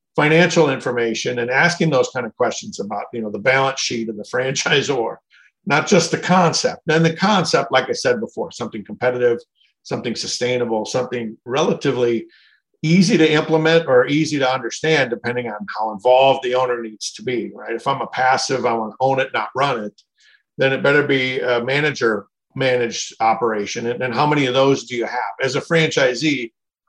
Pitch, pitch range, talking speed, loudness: 130 Hz, 120-155 Hz, 185 wpm, -18 LUFS